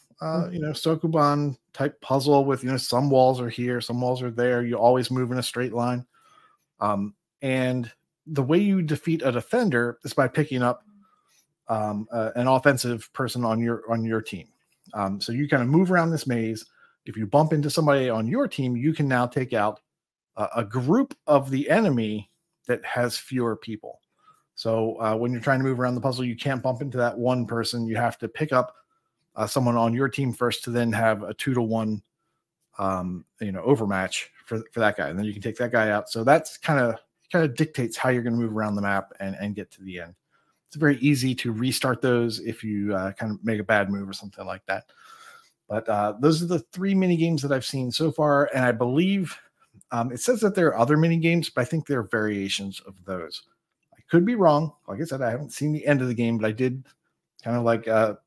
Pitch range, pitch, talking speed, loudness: 115-145 Hz, 125 Hz, 230 wpm, -24 LUFS